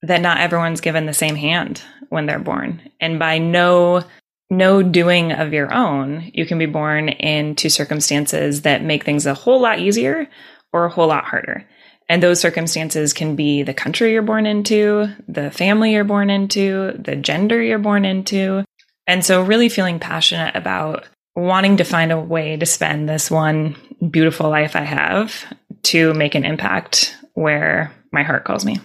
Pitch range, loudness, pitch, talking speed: 155-200 Hz, -17 LUFS, 170 Hz, 175 wpm